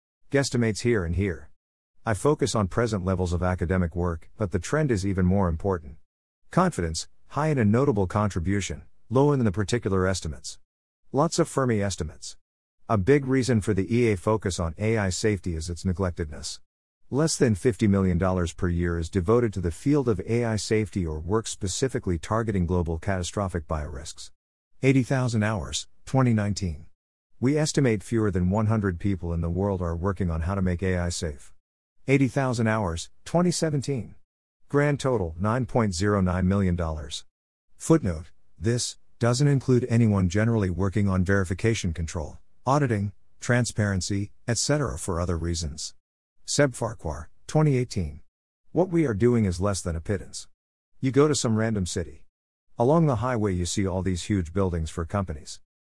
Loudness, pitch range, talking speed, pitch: -26 LUFS, 85-115 Hz, 150 wpm, 100 Hz